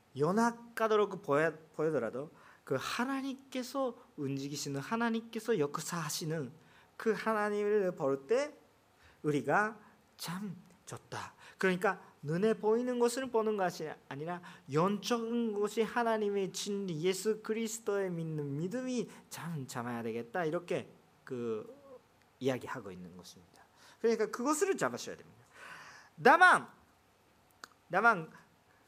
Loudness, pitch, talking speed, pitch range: -34 LUFS, 200 Hz, 265 characters per minute, 155-230 Hz